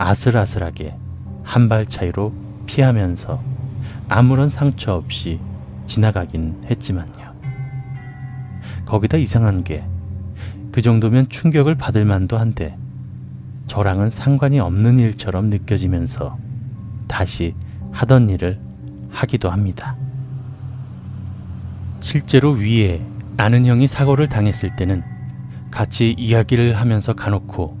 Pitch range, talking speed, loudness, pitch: 100-125 Hz, 230 characters per minute, -18 LUFS, 115 Hz